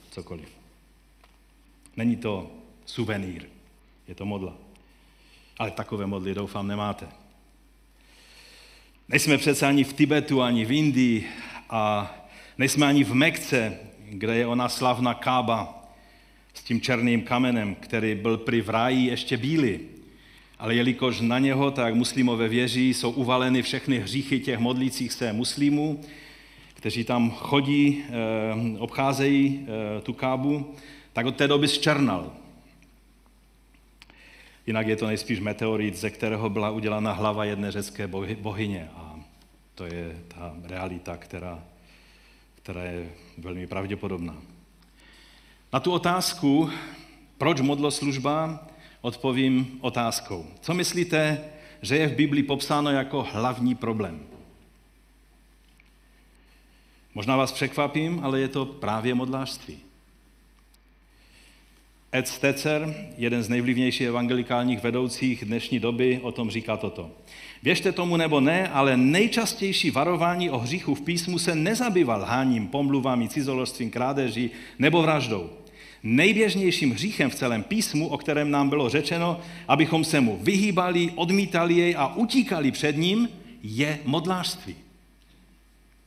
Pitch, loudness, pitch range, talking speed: 125 Hz, -25 LUFS, 110-145 Hz, 120 wpm